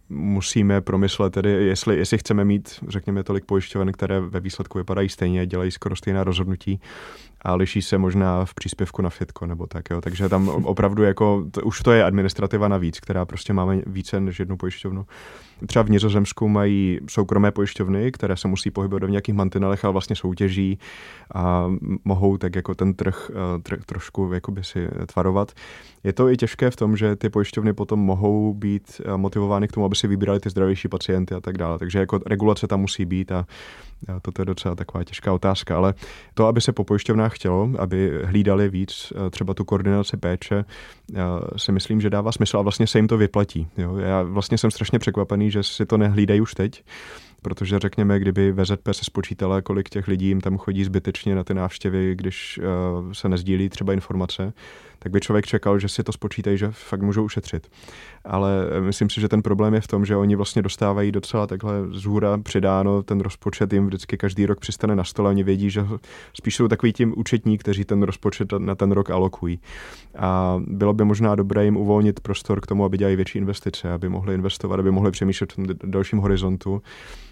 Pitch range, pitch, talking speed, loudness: 95-105 Hz, 100 Hz, 190 wpm, -22 LUFS